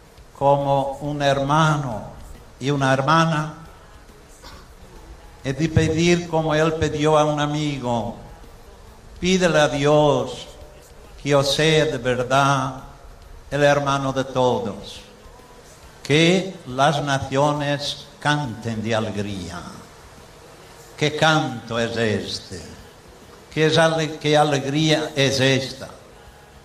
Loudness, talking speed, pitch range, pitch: -20 LUFS, 100 wpm, 105-150 Hz, 135 Hz